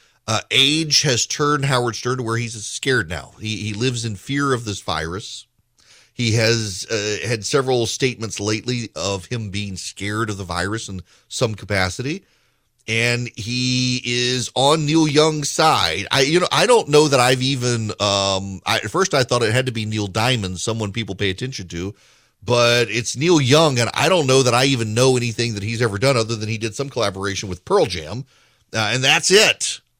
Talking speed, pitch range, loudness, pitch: 200 wpm, 105-130 Hz, -19 LUFS, 120 Hz